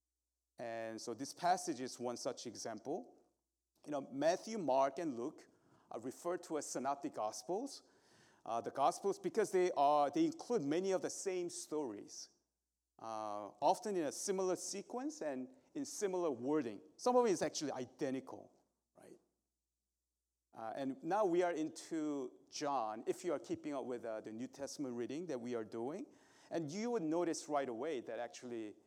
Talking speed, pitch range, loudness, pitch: 165 wpm, 115-190 Hz, -40 LUFS, 145 Hz